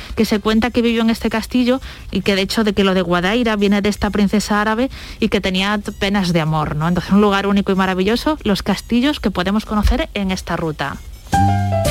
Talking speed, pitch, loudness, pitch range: 220 wpm, 205 Hz, -17 LUFS, 185-225 Hz